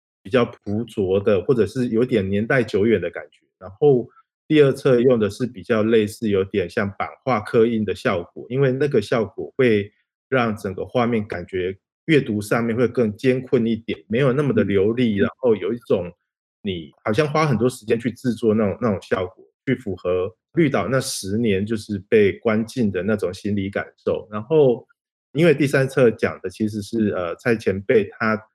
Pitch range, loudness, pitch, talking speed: 105-135 Hz, -21 LUFS, 115 Hz, 270 characters per minute